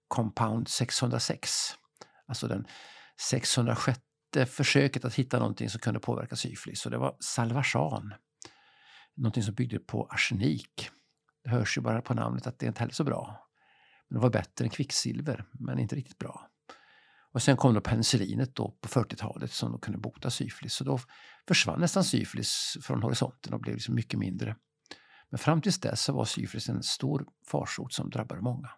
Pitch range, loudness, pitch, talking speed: 110-140 Hz, -31 LUFS, 125 Hz, 170 wpm